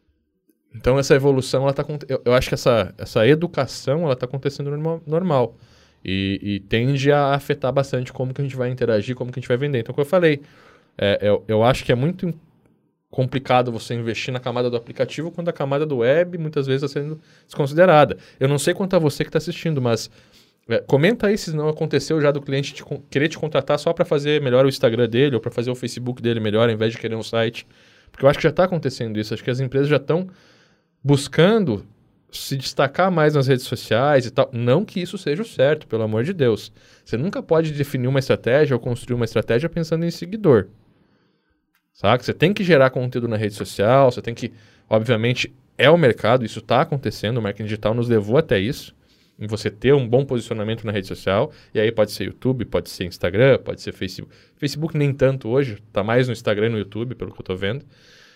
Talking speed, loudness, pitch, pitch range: 220 wpm, -20 LUFS, 130 Hz, 115-150 Hz